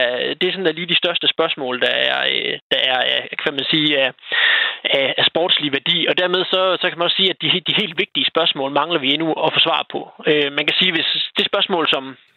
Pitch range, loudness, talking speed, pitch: 150-185 Hz, -17 LUFS, 230 wpm, 165 Hz